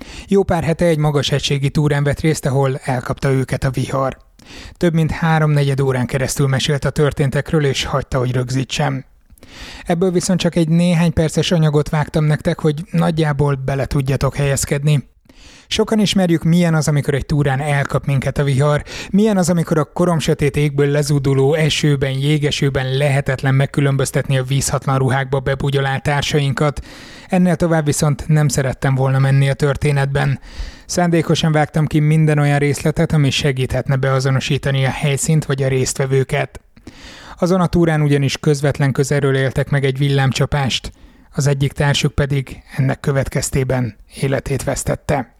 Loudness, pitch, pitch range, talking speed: -17 LUFS, 145 Hz, 135-155 Hz, 145 wpm